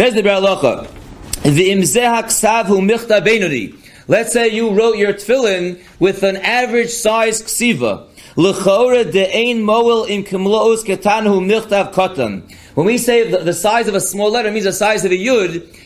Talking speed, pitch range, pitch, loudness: 180 wpm, 190-230 Hz, 210 Hz, -14 LUFS